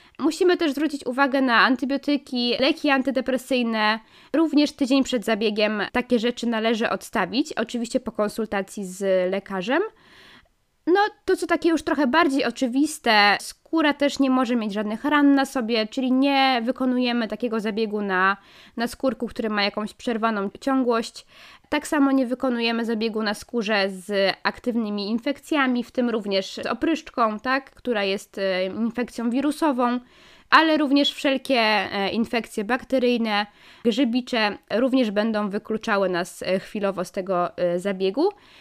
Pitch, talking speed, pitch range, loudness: 240 Hz, 130 wpm, 210-275 Hz, -23 LUFS